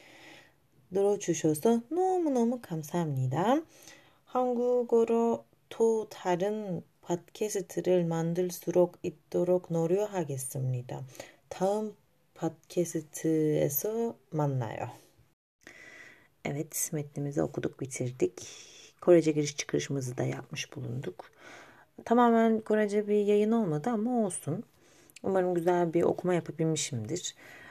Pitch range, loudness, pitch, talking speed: 155-215 Hz, -30 LUFS, 175 Hz, 65 wpm